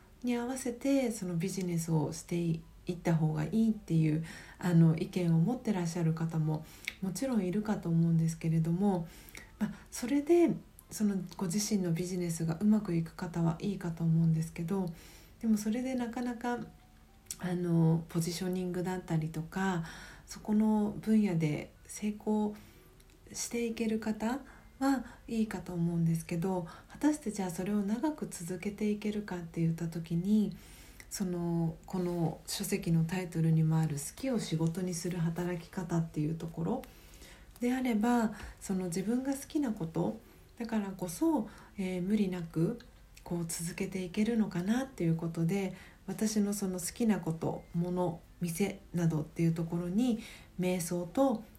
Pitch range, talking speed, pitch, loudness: 170-215 Hz, 305 characters per minute, 185 Hz, -33 LUFS